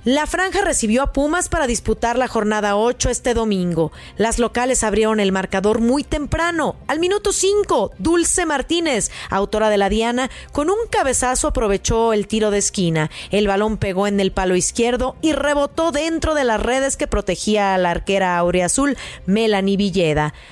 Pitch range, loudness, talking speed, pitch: 200-290 Hz, -18 LUFS, 170 wpm, 235 Hz